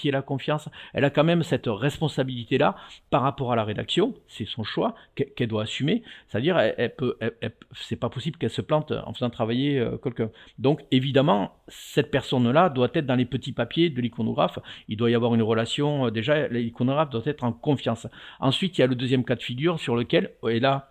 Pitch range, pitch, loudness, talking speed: 120-145 Hz, 130 Hz, -25 LUFS, 220 wpm